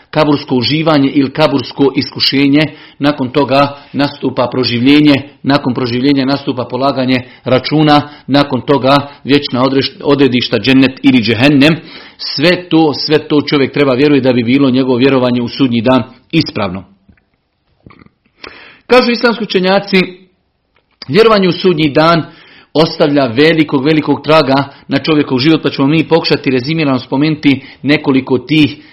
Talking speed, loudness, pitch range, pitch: 120 wpm, -11 LUFS, 130-155 Hz, 140 Hz